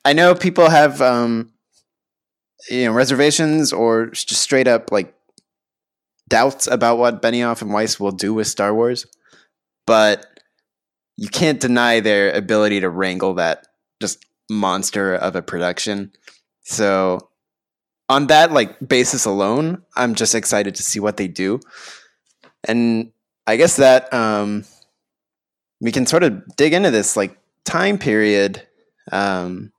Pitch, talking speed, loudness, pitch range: 115 Hz, 135 wpm, -17 LUFS, 100-125 Hz